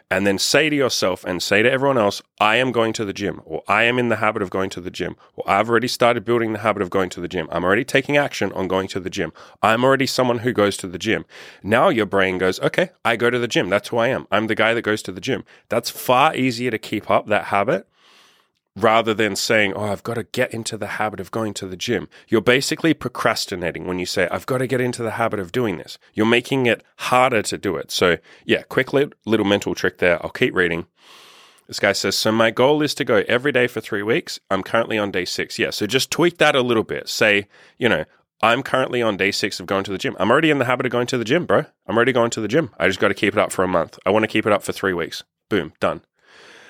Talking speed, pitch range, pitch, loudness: 275 wpm, 100-125 Hz, 110 Hz, -20 LUFS